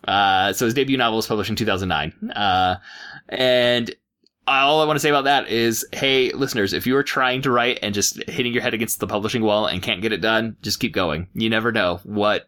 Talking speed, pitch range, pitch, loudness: 225 wpm, 105-125 Hz, 115 Hz, -20 LUFS